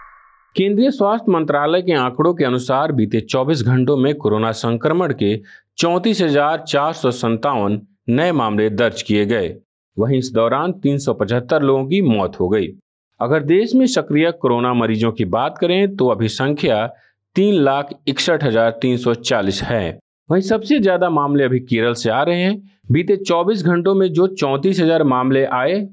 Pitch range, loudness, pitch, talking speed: 120-175 Hz, -17 LUFS, 140 Hz, 155 wpm